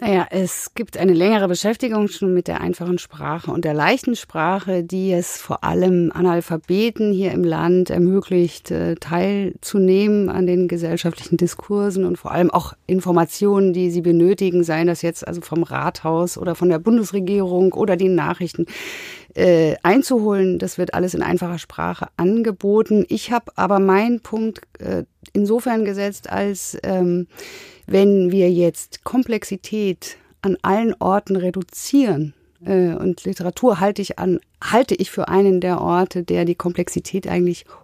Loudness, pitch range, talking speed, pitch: -19 LUFS, 175-200 Hz, 150 wpm, 185 Hz